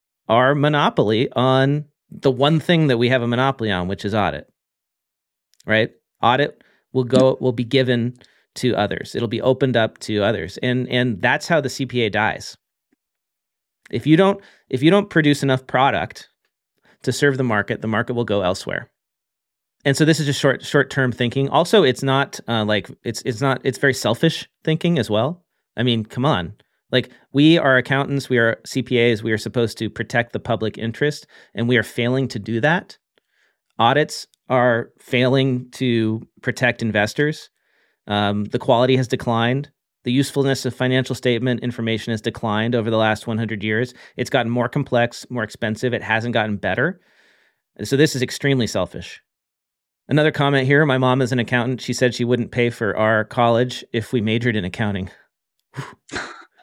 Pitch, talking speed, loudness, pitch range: 125 Hz, 175 wpm, -19 LUFS, 115-135 Hz